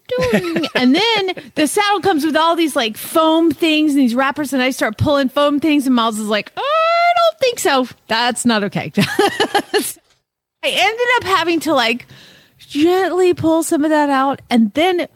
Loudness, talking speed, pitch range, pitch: -15 LUFS, 180 wpm, 265-360 Hz, 315 Hz